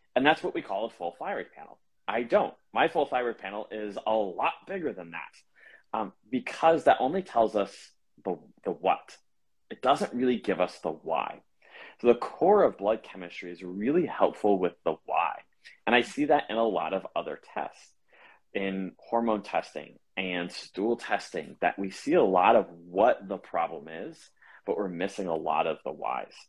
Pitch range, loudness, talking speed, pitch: 95-120 Hz, -29 LUFS, 190 wpm, 105 Hz